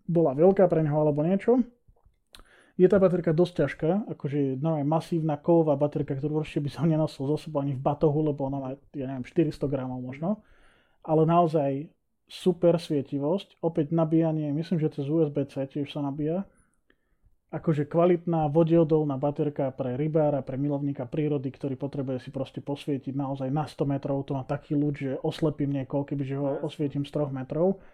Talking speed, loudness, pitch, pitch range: 170 wpm, -27 LUFS, 150 Hz, 140-165 Hz